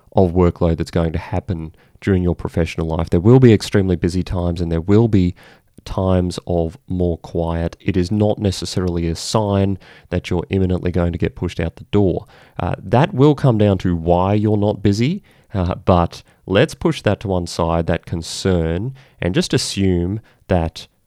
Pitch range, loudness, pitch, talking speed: 85-105 Hz, -18 LUFS, 90 Hz, 180 wpm